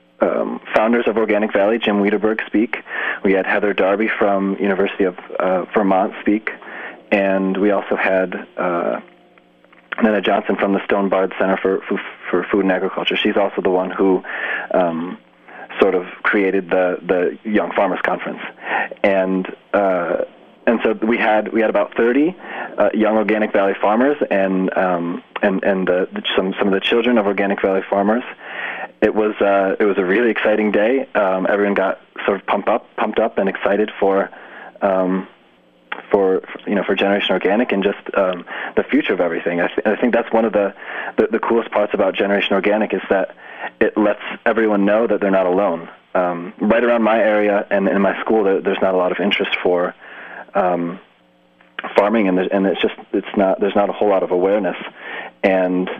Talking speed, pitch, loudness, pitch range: 185 wpm, 100 Hz, -18 LUFS, 95-105 Hz